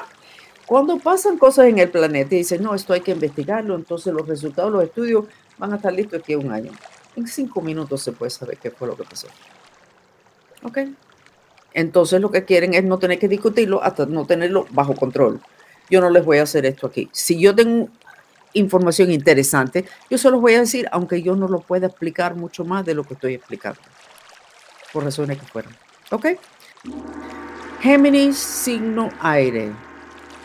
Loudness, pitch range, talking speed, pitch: -18 LUFS, 160-235 Hz, 180 wpm, 185 Hz